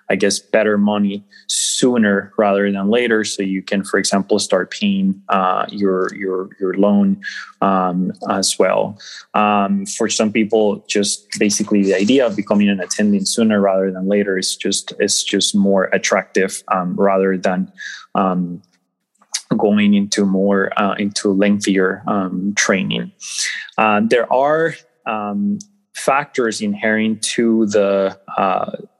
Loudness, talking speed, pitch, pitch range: -17 LUFS, 135 wpm, 100 Hz, 95-105 Hz